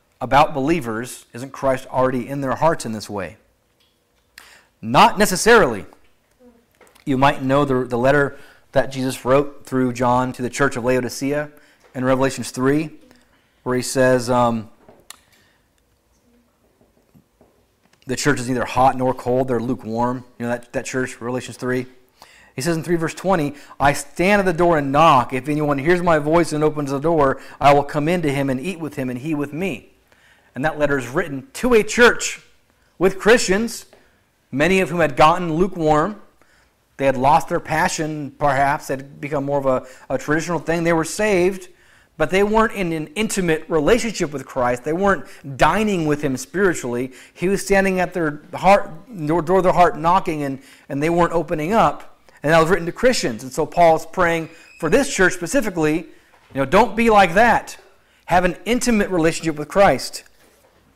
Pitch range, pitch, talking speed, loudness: 130-175 Hz, 150 Hz, 175 wpm, -19 LUFS